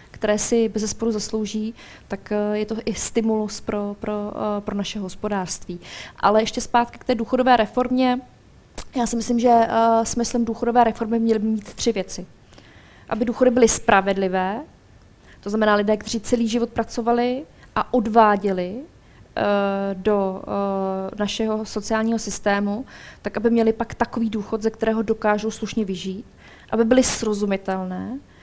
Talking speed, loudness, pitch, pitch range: 135 wpm, -21 LUFS, 220 Hz, 200-230 Hz